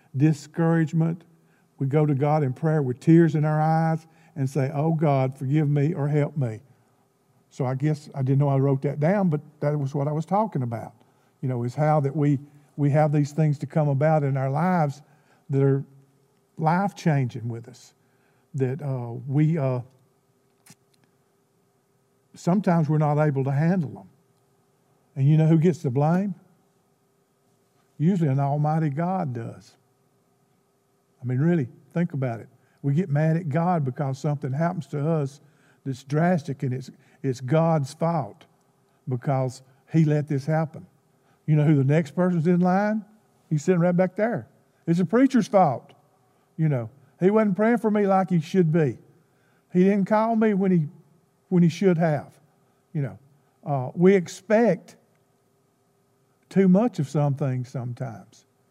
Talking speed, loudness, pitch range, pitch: 165 wpm, -24 LUFS, 135-165 Hz, 145 Hz